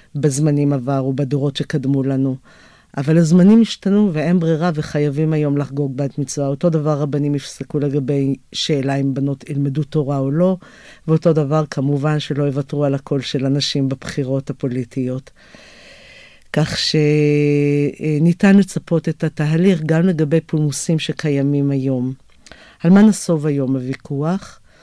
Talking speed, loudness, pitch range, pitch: 130 wpm, -17 LUFS, 140-160 Hz, 150 Hz